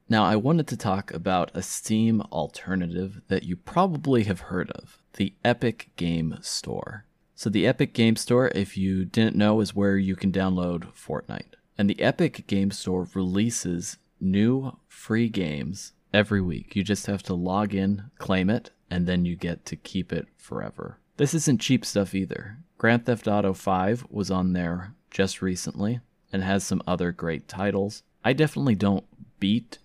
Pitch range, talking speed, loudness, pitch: 95-115 Hz, 170 wpm, -26 LUFS, 100 Hz